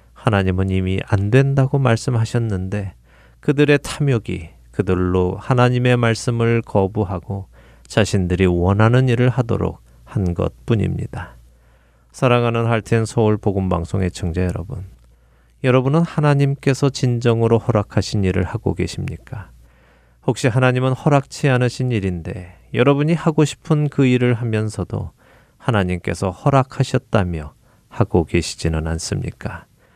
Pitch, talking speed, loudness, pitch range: 105 Hz, 295 characters per minute, -19 LUFS, 90-125 Hz